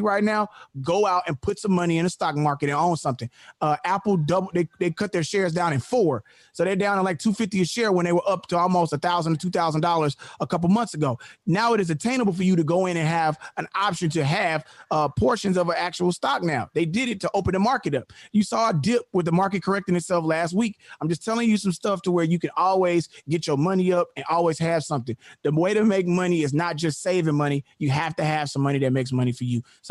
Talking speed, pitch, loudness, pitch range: 260 wpm, 175 Hz, -23 LUFS, 155-195 Hz